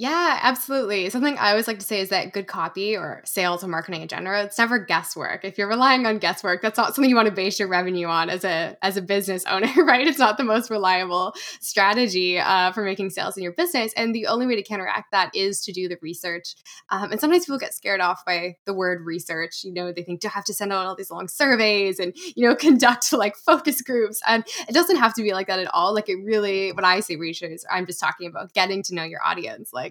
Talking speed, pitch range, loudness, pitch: 255 wpm, 180-230 Hz, -22 LUFS, 200 Hz